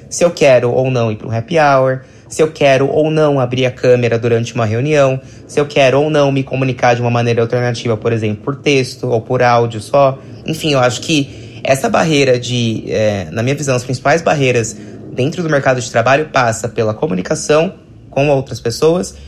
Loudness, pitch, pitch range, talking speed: -14 LUFS, 125 Hz, 115-140 Hz, 205 wpm